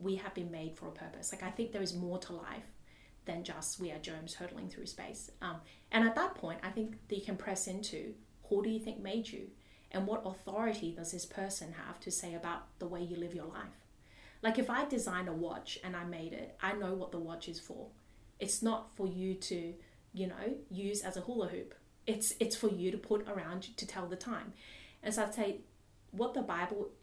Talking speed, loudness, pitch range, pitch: 230 wpm, -39 LUFS, 175-215 Hz, 190 Hz